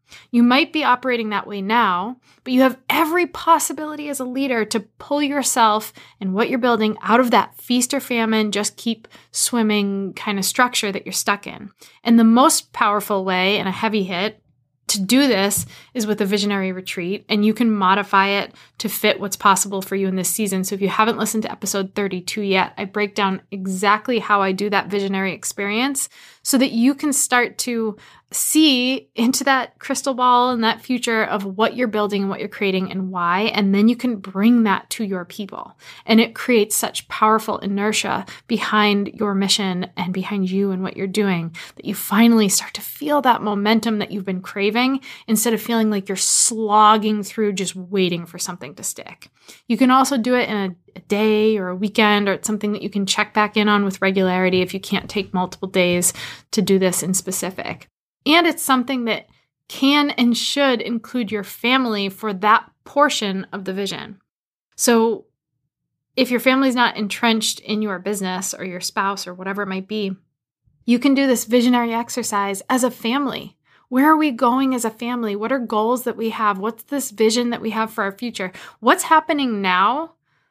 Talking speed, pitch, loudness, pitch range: 195 wpm, 215 Hz, -19 LUFS, 195-245 Hz